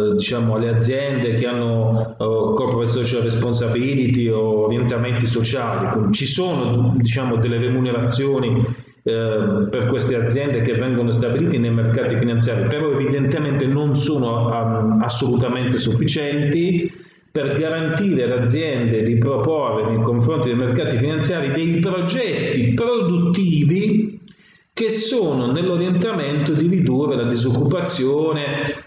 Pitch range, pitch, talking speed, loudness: 120-155 Hz, 125 Hz, 115 wpm, -19 LUFS